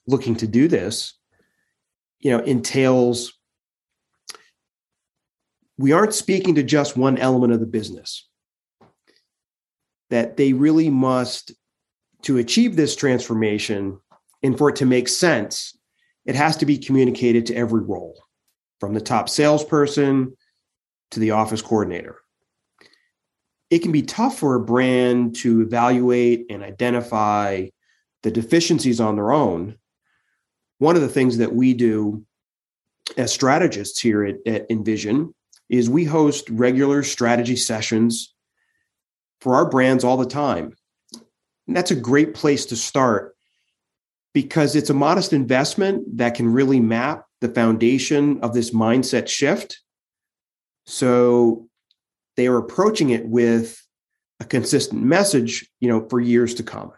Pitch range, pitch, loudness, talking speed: 115-145 Hz, 125 Hz, -19 LUFS, 130 wpm